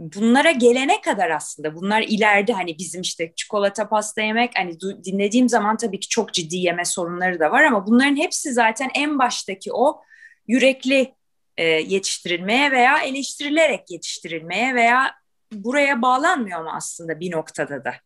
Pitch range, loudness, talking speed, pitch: 180-260 Hz, -20 LUFS, 145 wpm, 220 Hz